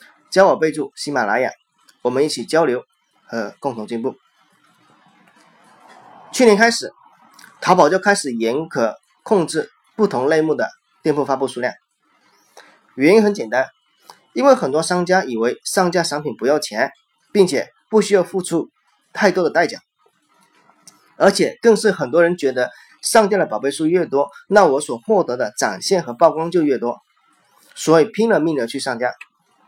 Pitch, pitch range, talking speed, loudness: 165 Hz, 140-205 Hz, 235 characters per minute, -18 LUFS